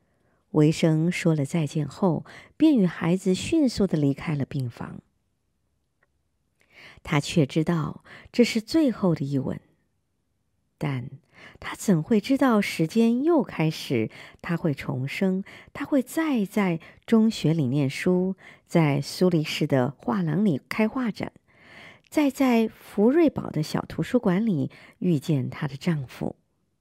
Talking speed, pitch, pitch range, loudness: 185 characters per minute, 170 Hz, 145-220 Hz, -25 LUFS